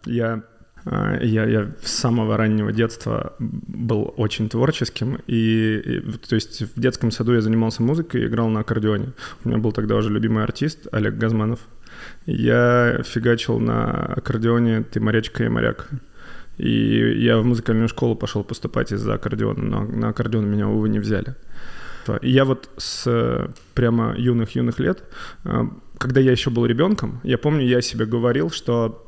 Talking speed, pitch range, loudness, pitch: 155 wpm, 110-120 Hz, -21 LUFS, 115 Hz